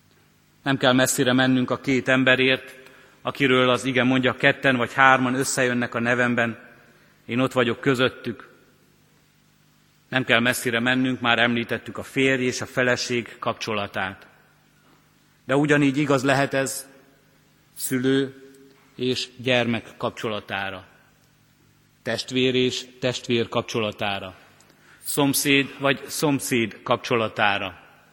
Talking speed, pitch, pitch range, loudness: 105 wpm, 130 Hz, 120-135 Hz, -22 LUFS